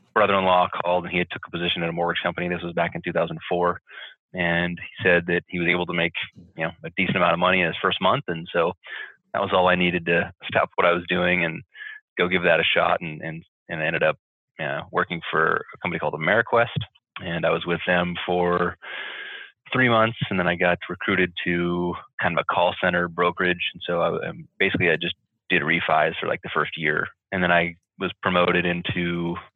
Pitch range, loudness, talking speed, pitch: 85-90 Hz, -23 LUFS, 220 wpm, 90 Hz